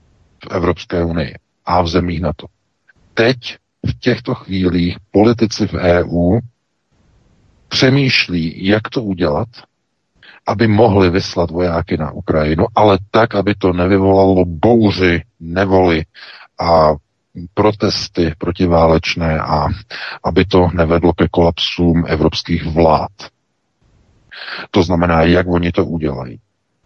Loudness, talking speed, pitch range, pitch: -15 LUFS, 110 wpm, 85-100 Hz, 90 Hz